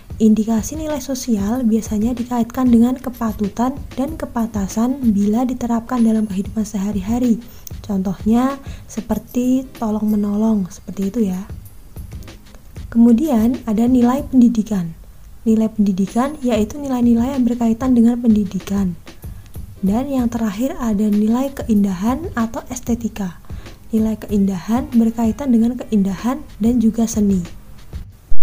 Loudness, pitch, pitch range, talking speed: -18 LUFS, 225 Hz, 200-245 Hz, 105 wpm